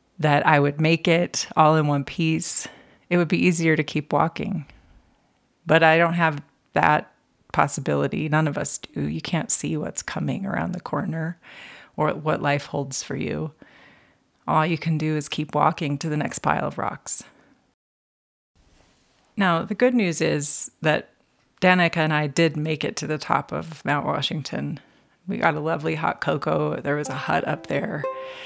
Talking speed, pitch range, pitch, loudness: 175 wpm, 145-170 Hz, 155 Hz, -23 LUFS